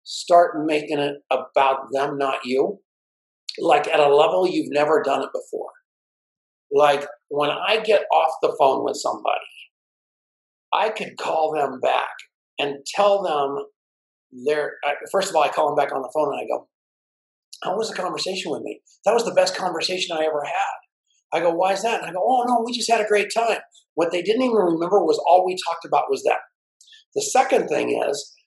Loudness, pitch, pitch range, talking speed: -21 LUFS, 170 Hz, 145-215 Hz, 195 wpm